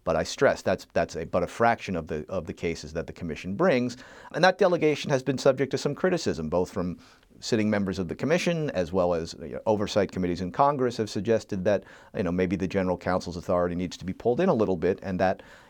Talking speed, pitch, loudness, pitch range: 240 wpm, 100 Hz, -27 LUFS, 90-140 Hz